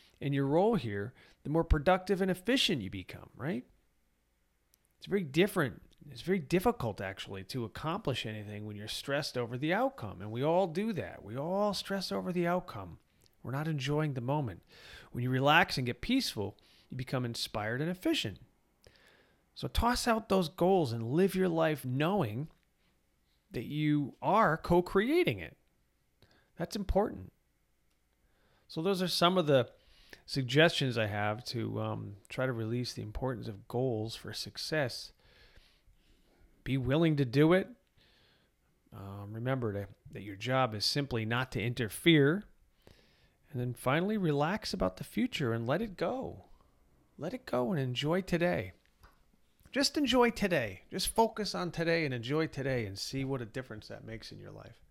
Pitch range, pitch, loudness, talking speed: 110-175 Hz, 135 Hz, -32 LUFS, 160 wpm